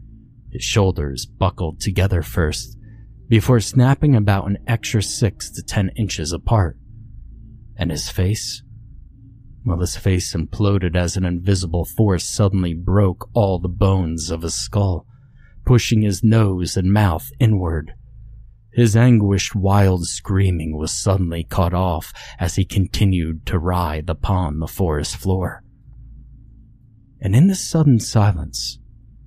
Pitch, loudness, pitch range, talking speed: 100 Hz, -19 LUFS, 90-115 Hz, 125 wpm